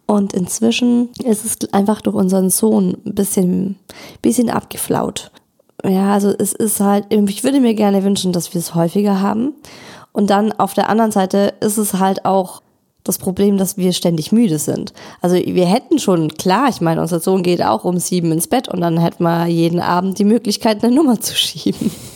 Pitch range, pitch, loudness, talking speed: 180-215 Hz, 200 Hz, -16 LUFS, 195 wpm